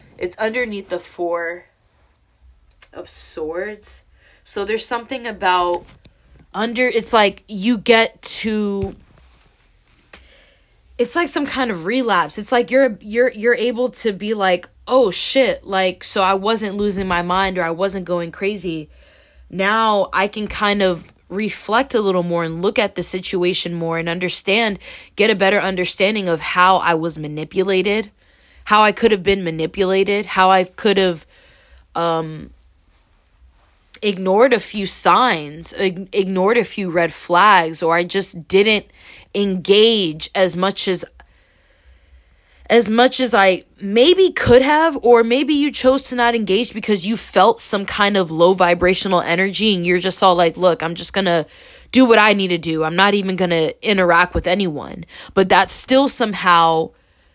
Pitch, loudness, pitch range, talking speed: 195 Hz, -16 LUFS, 175-220 Hz, 155 wpm